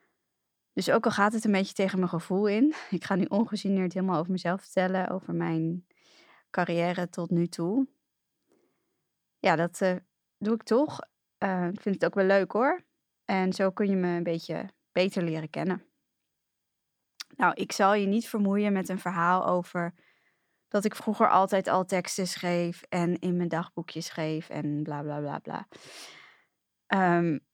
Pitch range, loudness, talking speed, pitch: 175-200 Hz, -28 LUFS, 170 wpm, 185 Hz